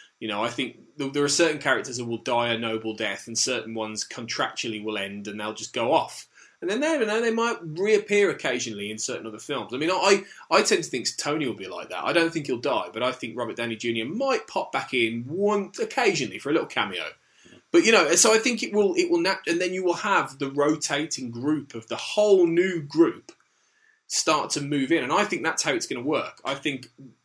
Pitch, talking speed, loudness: 145 Hz, 240 wpm, -25 LUFS